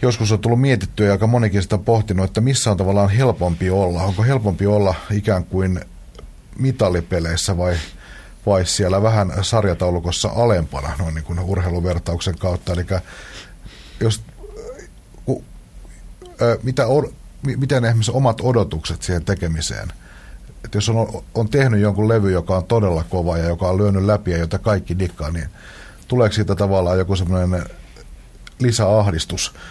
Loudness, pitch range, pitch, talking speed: -19 LUFS, 90-110 Hz, 100 Hz, 140 wpm